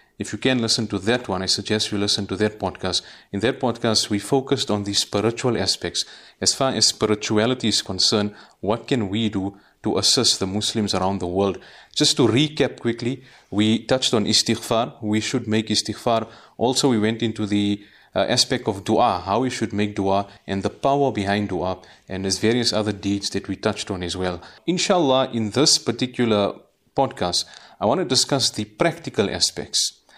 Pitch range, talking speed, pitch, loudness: 100-120 Hz, 185 wpm, 110 Hz, -21 LUFS